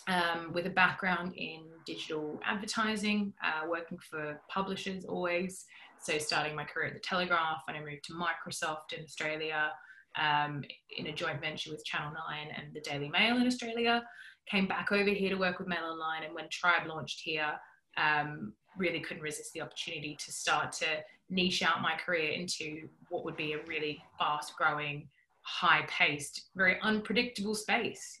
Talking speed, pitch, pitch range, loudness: 170 wpm, 165 Hz, 155-185 Hz, -33 LUFS